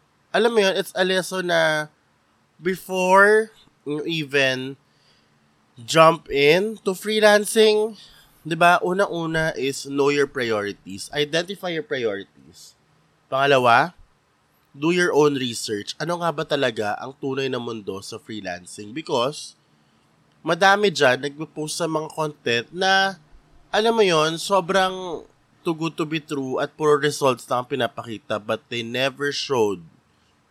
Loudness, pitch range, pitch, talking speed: -21 LUFS, 135-185 Hz, 155 Hz, 130 wpm